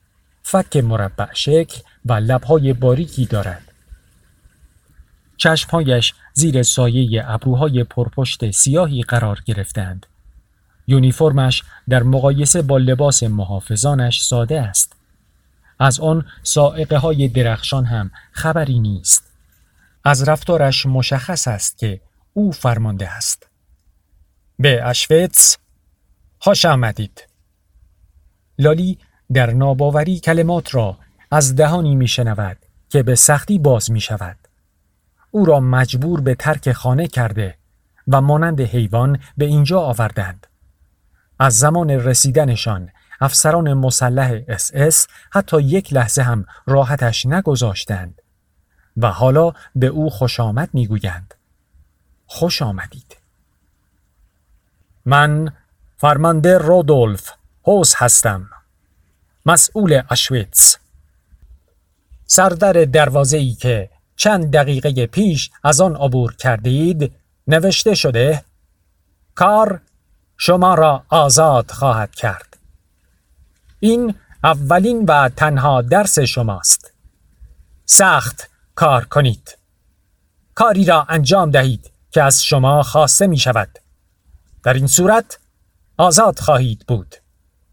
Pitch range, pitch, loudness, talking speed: 95-150 Hz, 125 Hz, -14 LUFS, 95 wpm